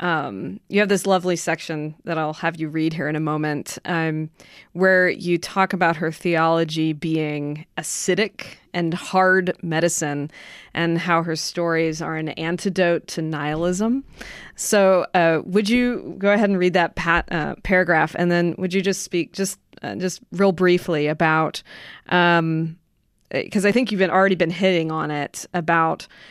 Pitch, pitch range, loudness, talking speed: 170 Hz, 160-185 Hz, -21 LUFS, 165 wpm